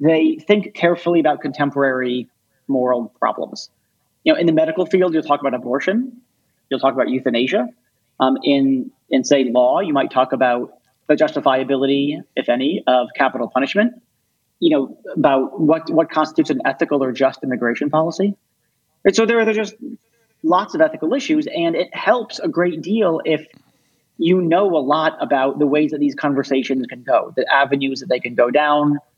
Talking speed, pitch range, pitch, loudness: 175 wpm, 130-180 Hz, 145 Hz, -18 LUFS